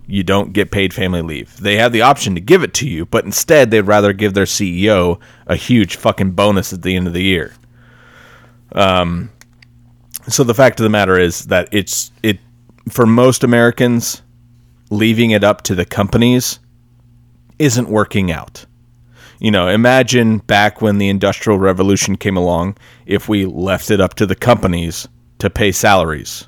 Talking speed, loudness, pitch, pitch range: 170 wpm, -13 LUFS, 105 Hz, 95-120 Hz